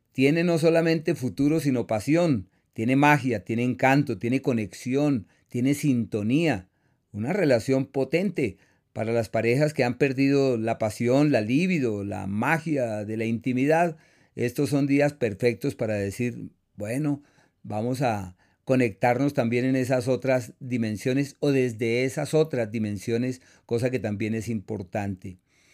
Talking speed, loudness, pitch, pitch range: 135 wpm, -25 LUFS, 125 Hz, 115-140 Hz